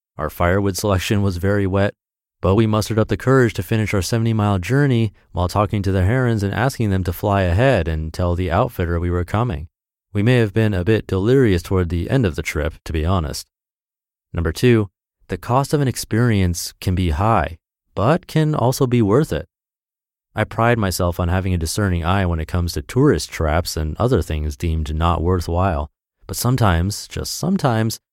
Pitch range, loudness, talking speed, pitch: 90-115 Hz, -19 LUFS, 195 wpm, 100 Hz